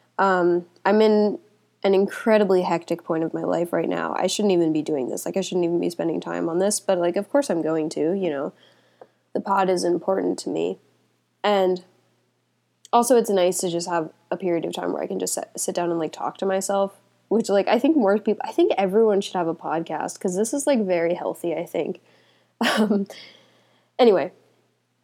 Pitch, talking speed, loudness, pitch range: 190 Hz, 210 wpm, -23 LUFS, 175-205 Hz